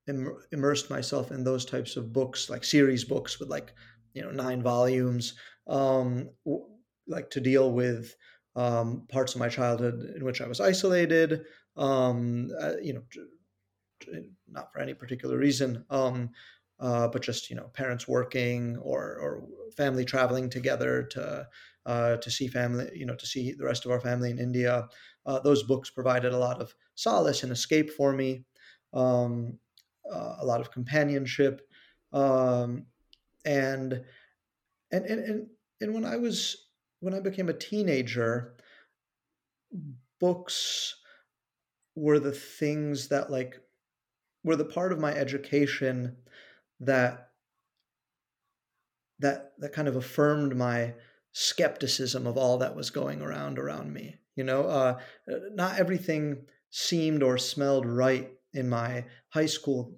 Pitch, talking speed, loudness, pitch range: 130 Hz, 140 wpm, -29 LUFS, 125-145 Hz